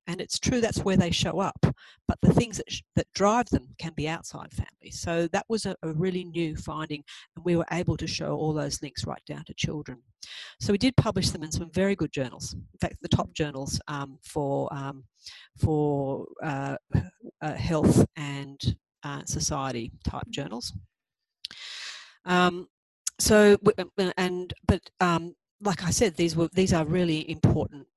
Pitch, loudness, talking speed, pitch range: 160 Hz, -27 LUFS, 175 wpm, 140-180 Hz